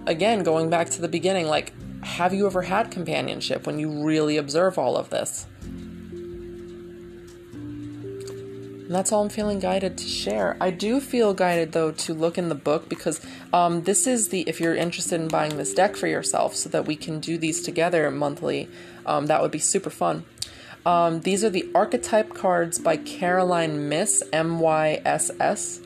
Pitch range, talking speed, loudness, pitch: 155-185 Hz, 180 wpm, -24 LUFS, 170 Hz